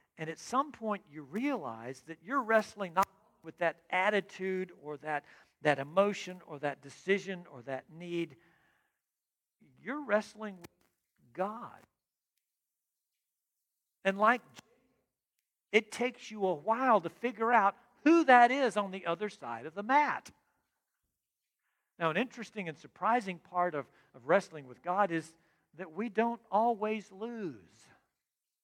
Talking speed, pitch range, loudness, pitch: 135 wpm, 165-220 Hz, -32 LUFS, 195 Hz